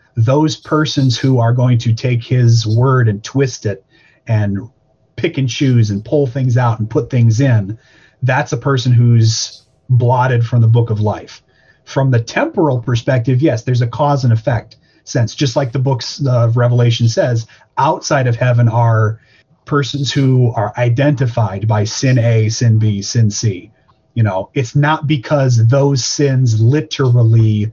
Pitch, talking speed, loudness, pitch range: 125 Hz, 160 wpm, -14 LUFS, 115-135 Hz